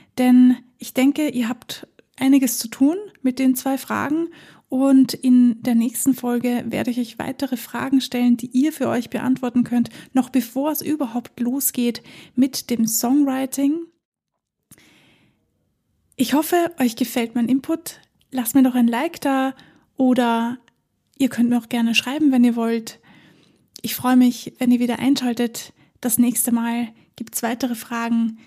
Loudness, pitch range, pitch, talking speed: -20 LUFS, 240-270 Hz, 250 Hz, 155 wpm